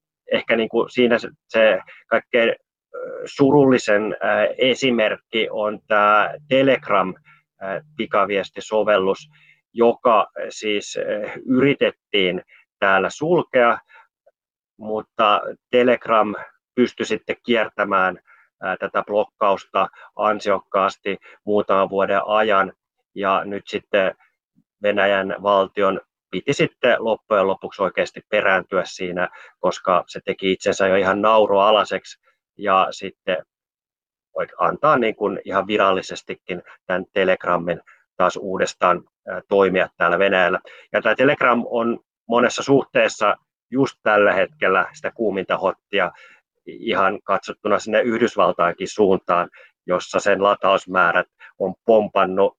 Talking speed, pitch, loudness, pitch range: 95 wpm, 110 Hz, -20 LUFS, 100-130 Hz